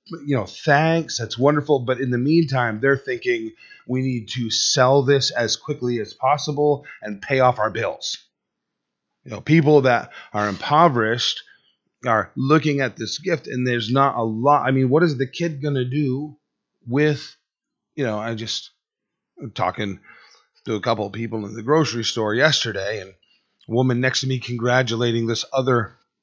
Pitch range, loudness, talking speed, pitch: 115-145 Hz, -21 LUFS, 175 wpm, 130 Hz